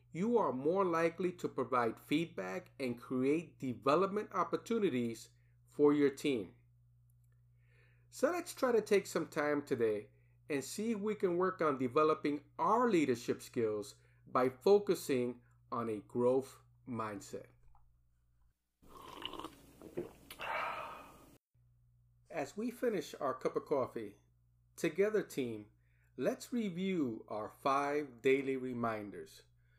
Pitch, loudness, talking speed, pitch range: 130 Hz, -36 LUFS, 110 wpm, 115-160 Hz